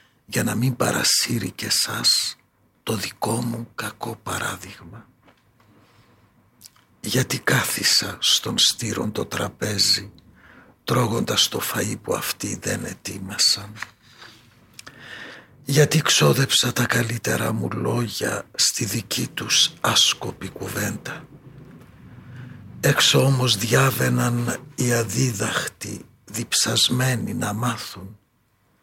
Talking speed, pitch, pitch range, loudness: 90 wpm, 120 Hz, 105-125 Hz, -21 LUFS